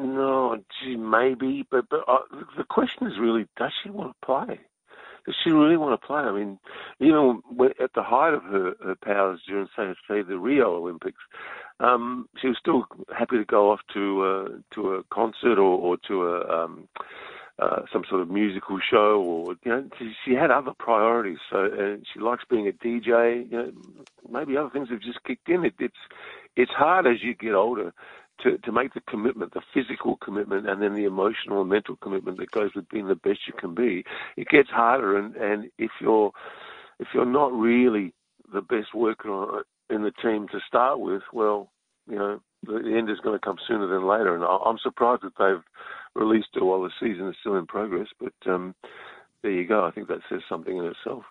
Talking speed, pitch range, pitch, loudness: 205 wpm, 100-130 Hz, 115 Hz, -25 LUFS